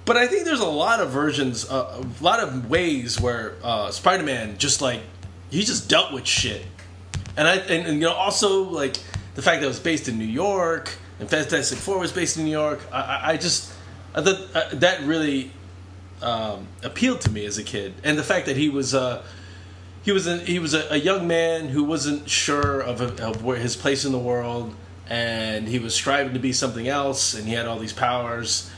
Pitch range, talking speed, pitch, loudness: 110-155 Hz, 215 wpm, 130 Hz, -23 LUFS